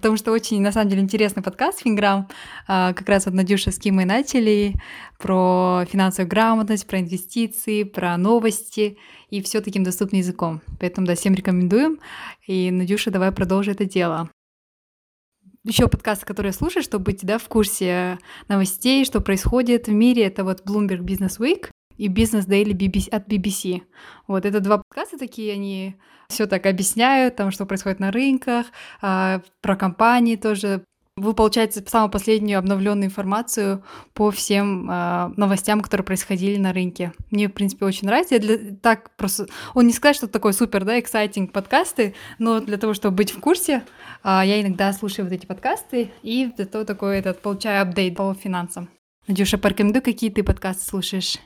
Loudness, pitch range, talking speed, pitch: -21 LUFS, 190-220 Hz, 160 wpm, 205 Hz